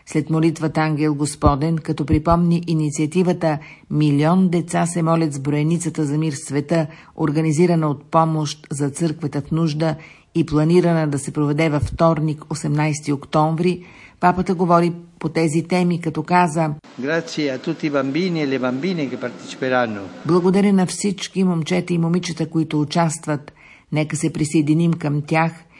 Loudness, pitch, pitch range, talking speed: -20 LUFS, 160 Hz, 150-170 Hz, 120 wpm